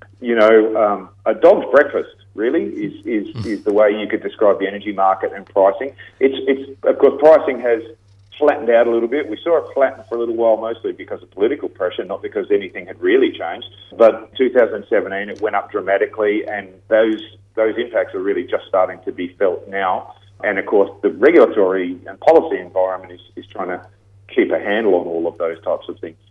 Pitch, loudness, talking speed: 115 Hz, -17 LUFS, 205 wpm